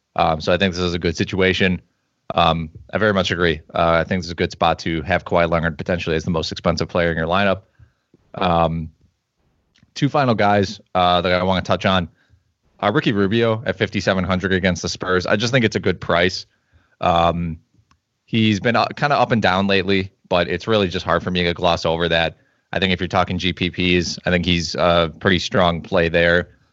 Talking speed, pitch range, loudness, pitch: 215 wpm, 85-100 Hz, -19 LUFS, 90 Hz